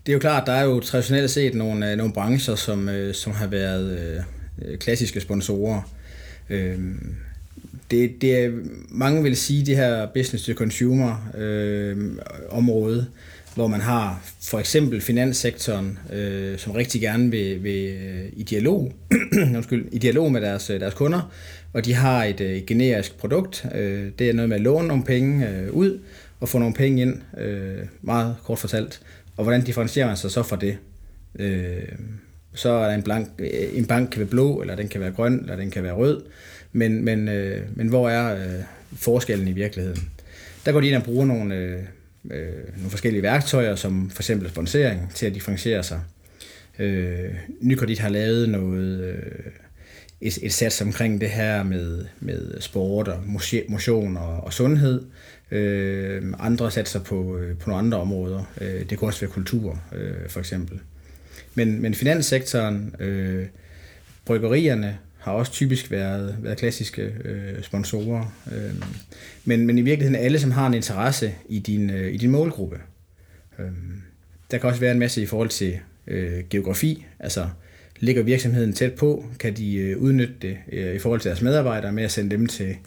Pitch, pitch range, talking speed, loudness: 105 Hz, 95-120 Hz, 160 wpm, -23 LUFS